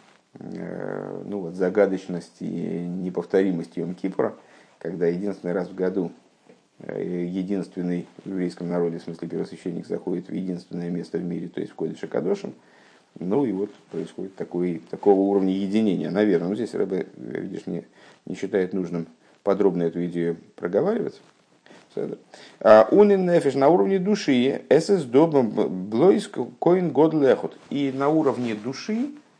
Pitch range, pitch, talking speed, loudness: 85-135 Hz, 95 Hz, 130 wpm, -24 LUFS